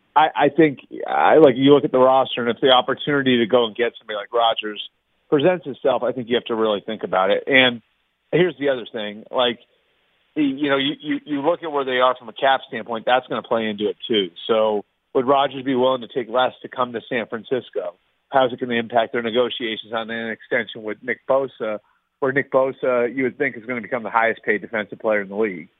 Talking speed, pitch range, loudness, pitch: 240 wpm, 115-135 Hz, -20 LUFS, 125 Hz